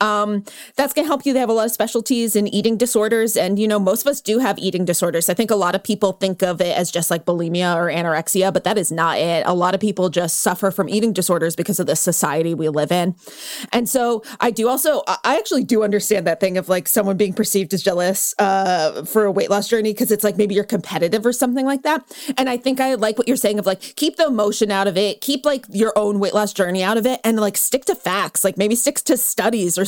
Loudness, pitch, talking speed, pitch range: -18 LUFS, 210 Hz, 265 wpm, 185-235 Hz